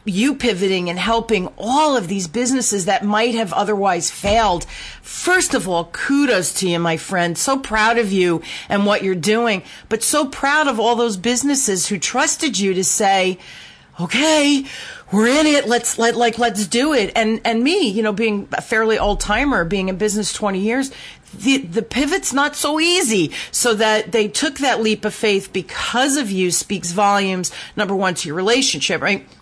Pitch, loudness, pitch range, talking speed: 220 Hz, -17 LUFS, 195-260 Hz, 185 wpm